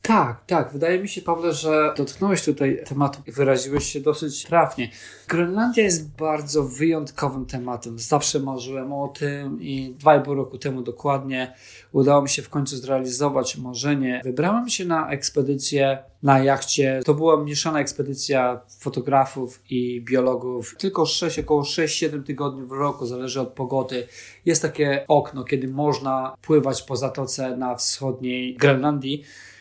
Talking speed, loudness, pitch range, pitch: 145 wpm, -22 LUFS, 130-150 Hz, 140 Hz